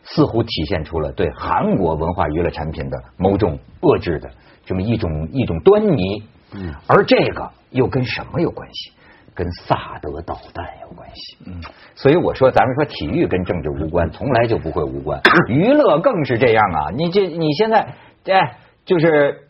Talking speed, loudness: 260 characters per minute, -17 LUFS